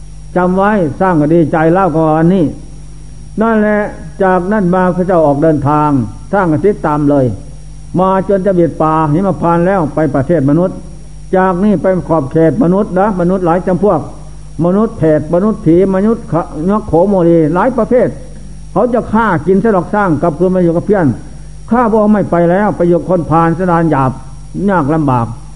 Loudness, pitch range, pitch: -11 LUFS, 155-190 Hz, 170 Hz